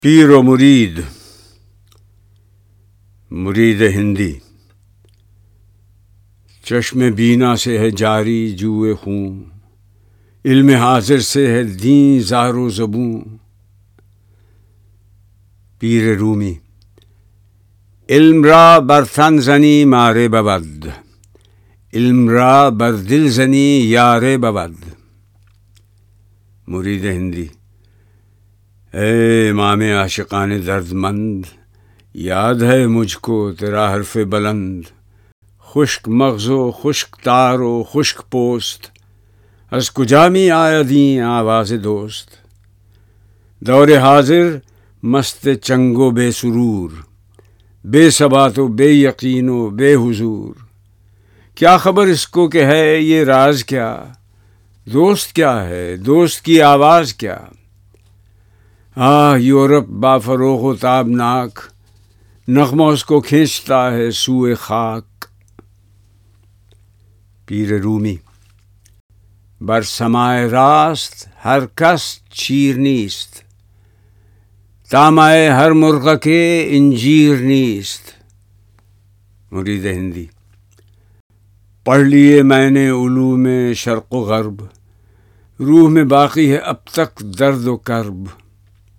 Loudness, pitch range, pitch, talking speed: -12 LUFS, 100-130 Hz, 110 Hz, 95 wpm